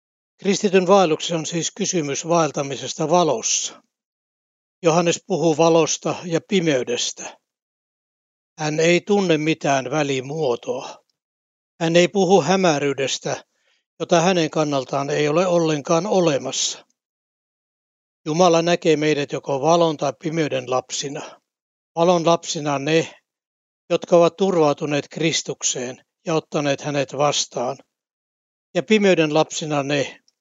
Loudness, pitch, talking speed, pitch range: -20 LUFS, 160 Hz, 100 wpm, 145-175 Hz